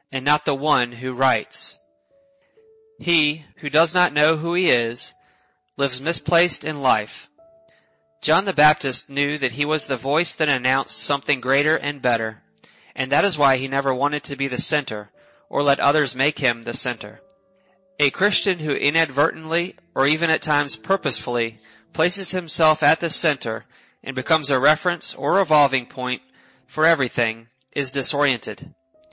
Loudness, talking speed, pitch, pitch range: -20 LUFS, 155 wpm, 145 Hz, 130-165 Hz